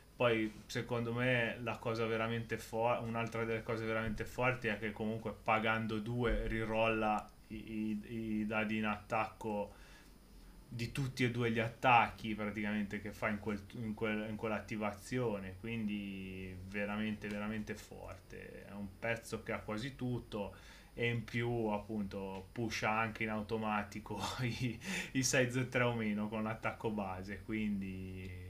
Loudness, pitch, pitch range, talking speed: -38 LUFS, 110 Hz, 105-115 Hz, 140 wpm